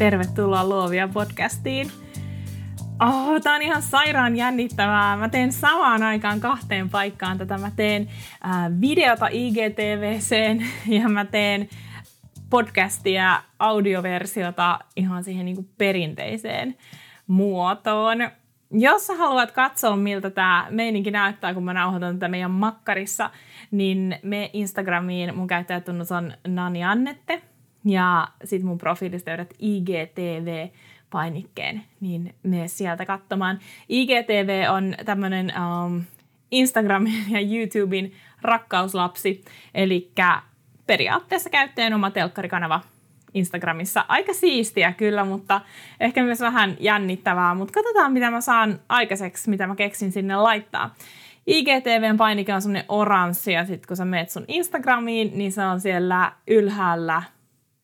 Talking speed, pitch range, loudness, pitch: 120 wpm, 180-220 Hz, -22 LUFS, 195 Hz